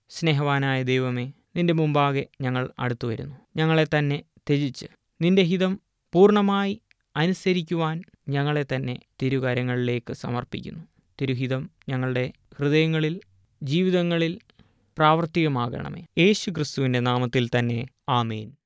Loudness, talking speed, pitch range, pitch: -24 LUFS, 85 wpm, 125-170 Hz, 145 Hz